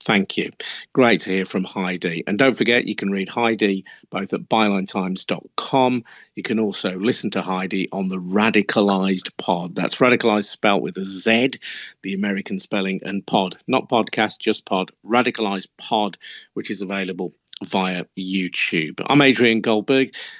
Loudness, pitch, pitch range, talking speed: -21 LUFS, 100 Hz, 95-110 Hz, 155 wpm